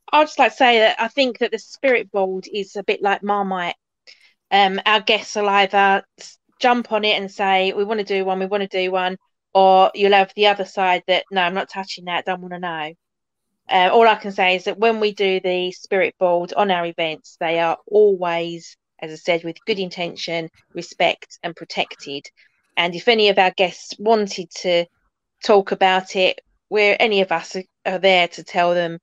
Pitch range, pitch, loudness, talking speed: 180-210 Hz, 190 Hz, -18 LUFS, 210 wpm